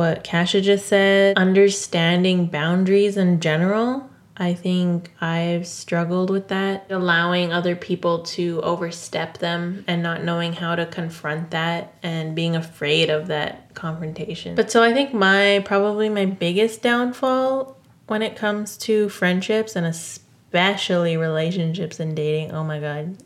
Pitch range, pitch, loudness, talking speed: 165-200 Hz, 175 Hz, -21 LUFS, 140 wpm